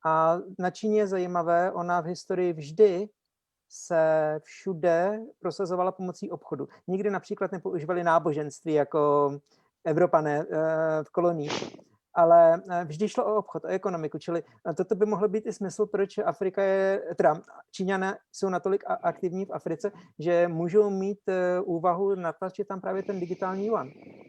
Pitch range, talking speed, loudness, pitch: 165-195 Hz, 140 wpm, -27 LUFS, 180 Hz